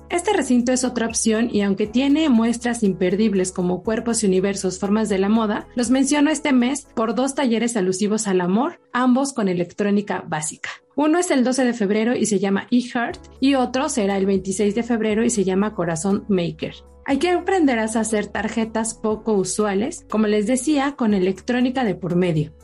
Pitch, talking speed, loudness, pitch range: 220 Hz, 185 wpm, -20 LUFS, 195-250 Hz